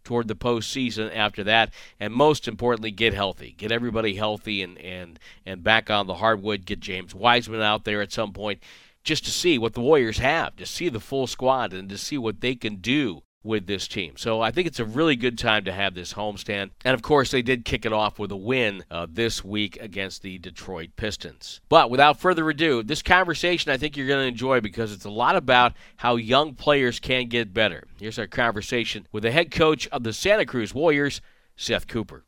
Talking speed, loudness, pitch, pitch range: 215 wpm, -23 LUFS, 115 Hz, 105-130 Hz